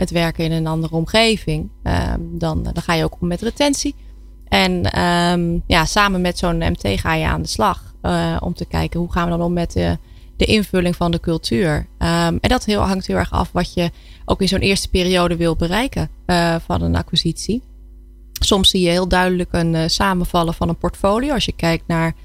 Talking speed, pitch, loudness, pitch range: 215 wpm, 170 Hz, -18 LUFS, 160-185 Hz